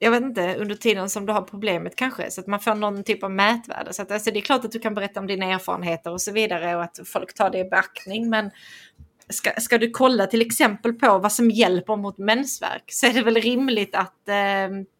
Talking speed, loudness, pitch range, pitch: 245 wpm, -22 LUFS, 195-230 Hz, 210 Hz